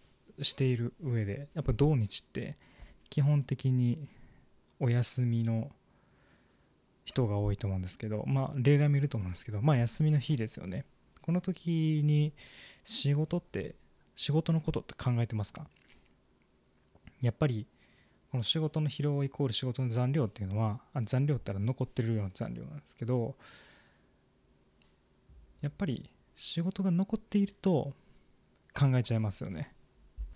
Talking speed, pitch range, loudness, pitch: 290 characters per minute, 115-150 Hz, -32 LUFS, 130 Hz